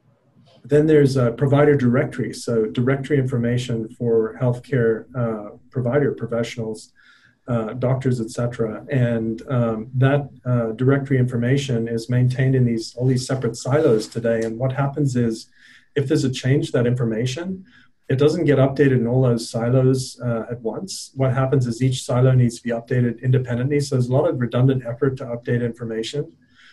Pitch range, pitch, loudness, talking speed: 115-135 Hz, 125 Hz, -21 LUFS, 165 wpm